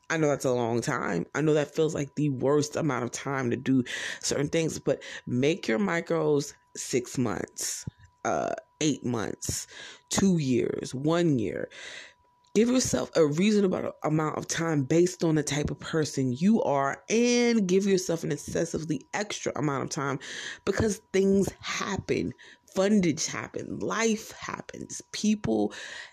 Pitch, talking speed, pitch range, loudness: 160 Hz, 150 wpm, 140-210 Hz, -28 LUFS